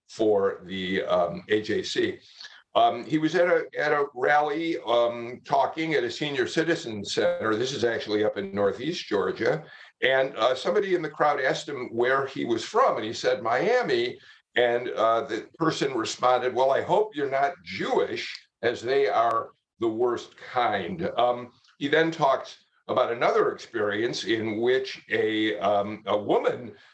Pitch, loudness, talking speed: 145 Hz, -26 LUFS, 160 wpm